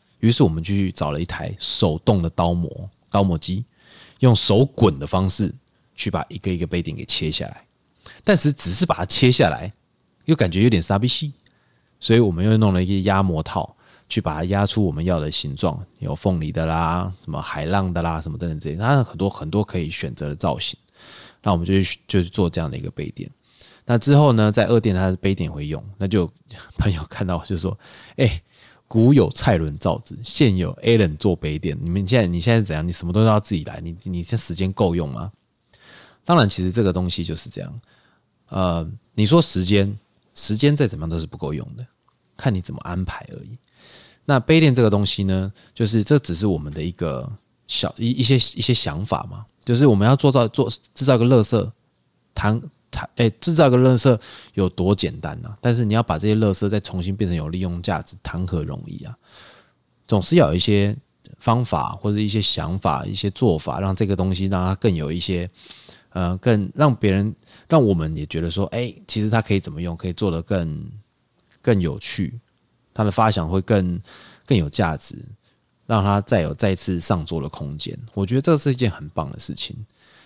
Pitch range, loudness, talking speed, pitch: 90-115 Hz, -20 LUFS, 295 characters per minute, 100 Hz